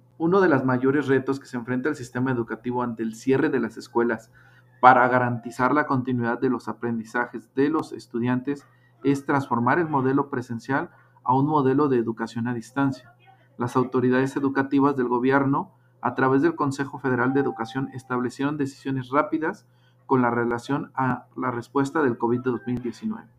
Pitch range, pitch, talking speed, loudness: 120-140 Hz, 130 Hz, 160 wpm, -24 LUFS